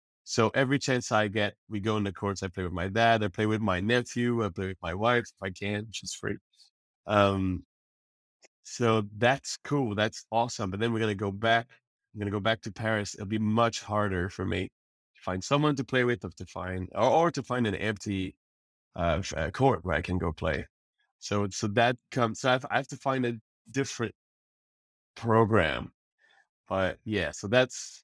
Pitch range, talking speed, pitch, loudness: 95-120 Hz, 200 wpm, 110 Hz, -29 LUFS